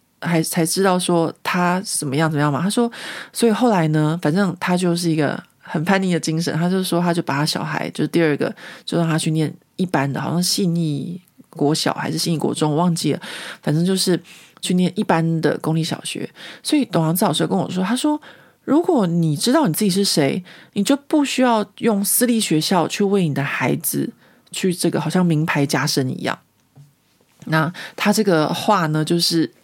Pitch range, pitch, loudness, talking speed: 155-195 Hz, 170 Hz, -19 LUFS, 285 characters per minute